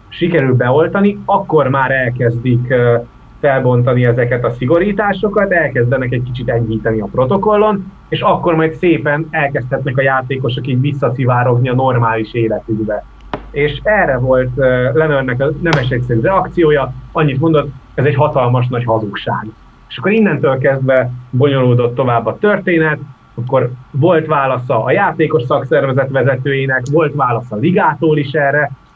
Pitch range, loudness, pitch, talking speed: 125-155 Hz, -14 LUFS, 135 Hz, 135 wpm